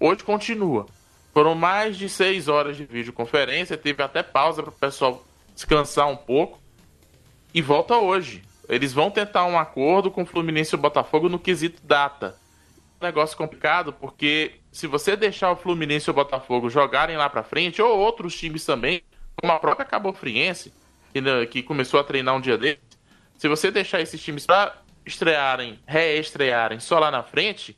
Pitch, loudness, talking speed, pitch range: 155 Hz, -22 LUFS, 165 wpm, 140-175 Hz